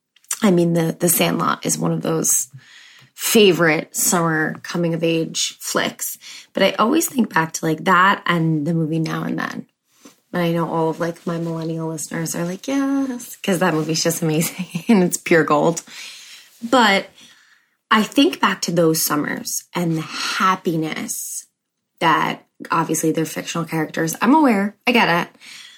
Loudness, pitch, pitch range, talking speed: -19 LUFS, 170 Hz, 160-205 Hz, 165 wpm